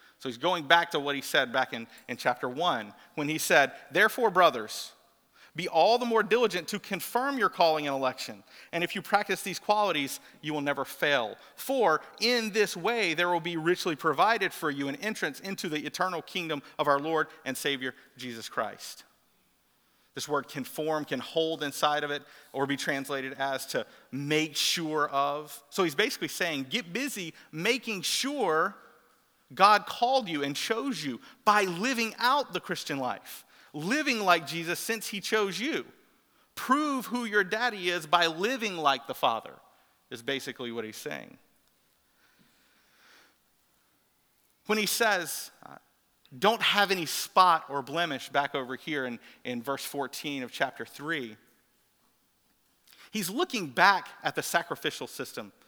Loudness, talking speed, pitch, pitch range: -29 LUFS, 160 wpm, 170 Hz, 145-215 Hz